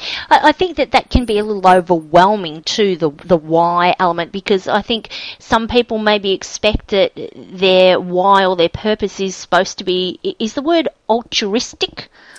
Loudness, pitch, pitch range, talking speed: -15 LUFS, 195 Hz, 180-230 Hz, 170 wpm